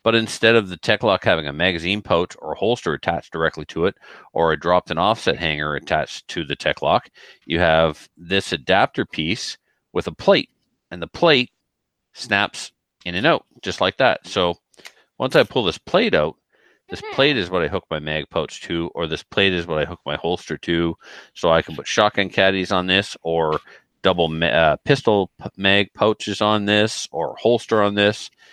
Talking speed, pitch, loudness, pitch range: 200 wpm, 90 Hz, -20 LUFS, 85-105 Hz